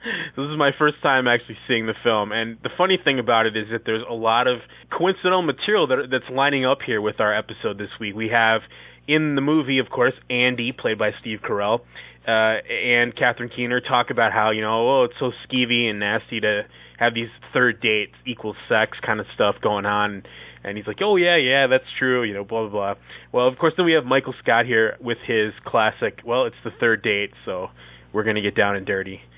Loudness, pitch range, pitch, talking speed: -21 LUFS, 105-130 Hz, 115 Hz, 225 wpm